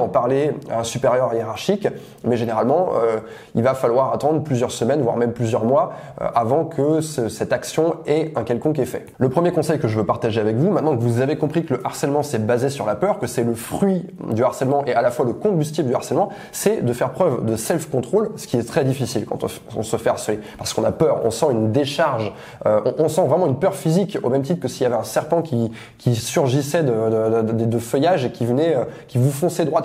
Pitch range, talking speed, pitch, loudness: 115-160 Hz, 250 wpm, 130 Hz, -20 LUFS